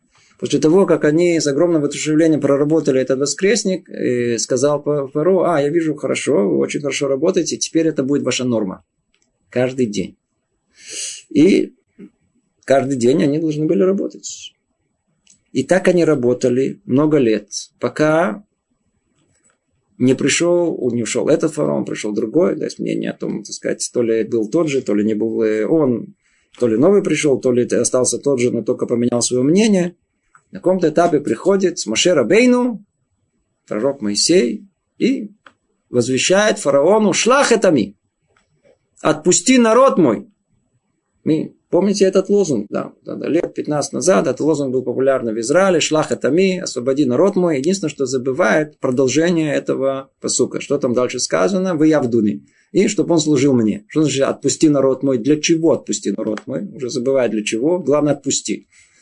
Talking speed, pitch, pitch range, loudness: 155 wpm, 145 Hz, 125-170 Hz, -17 LUFS